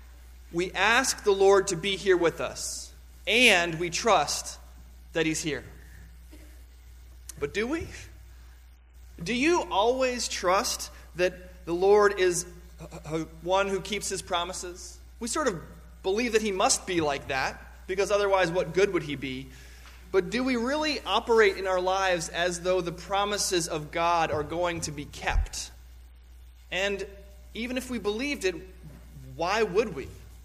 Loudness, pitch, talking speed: -27 LUFS, 175 Hz, 150 wpm